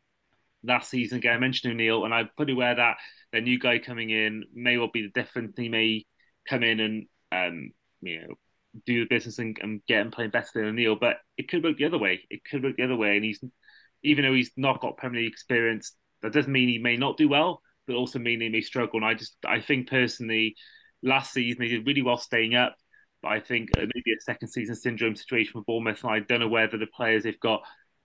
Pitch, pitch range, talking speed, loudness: 120 Hz, 110-125 Hz, 240 wpm, -26 LUFS